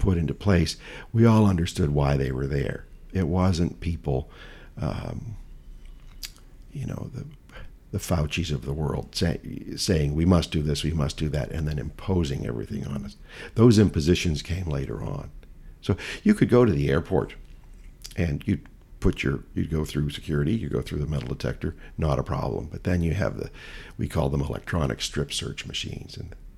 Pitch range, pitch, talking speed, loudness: 75-95 Hz, 80 Hz, 180 wpm, -26 LUFS